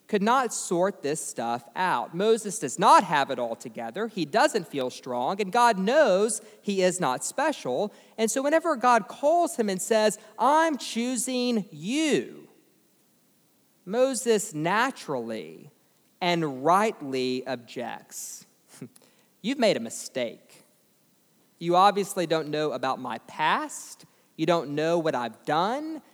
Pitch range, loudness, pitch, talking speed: 155-250 Hz, -26 LUFS, 205 Hz, 130 wpm